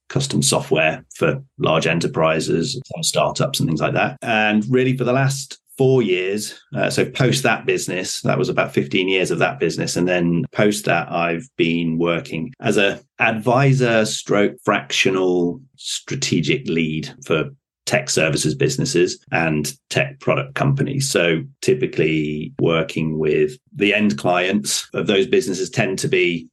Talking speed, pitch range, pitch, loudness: 145 wpm, 80-125 Hz, 95 Hz, -19 LUFS